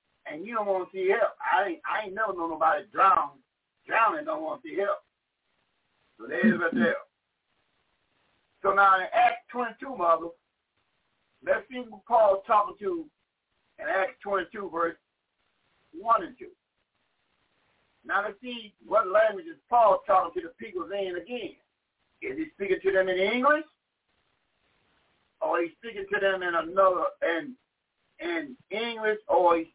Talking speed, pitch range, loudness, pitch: 155 wpm, 195-320 Hz, -27 LUFS, 230 Hz